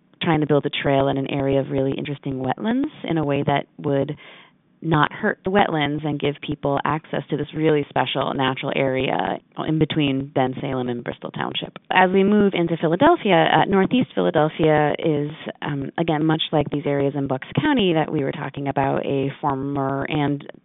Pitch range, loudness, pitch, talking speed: 135-160 Hz, -21 LUFS, 145 Hz, 185 wpm